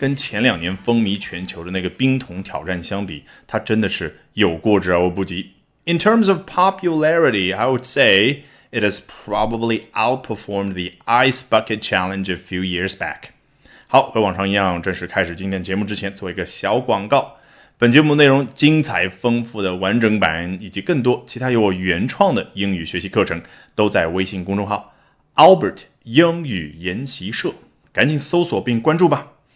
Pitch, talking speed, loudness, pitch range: 105 Hz, 390 characters per minute, -18 LUFS, 95-130 Hz